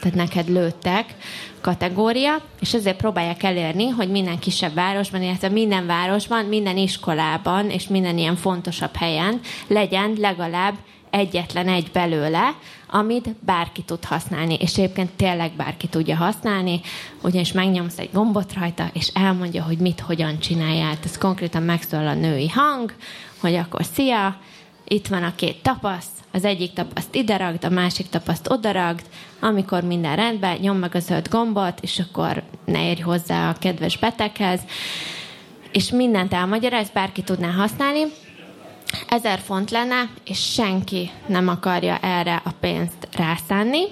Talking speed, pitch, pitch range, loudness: 145 wpm, 185 Hz, 175-205 Hz, -22 LUFS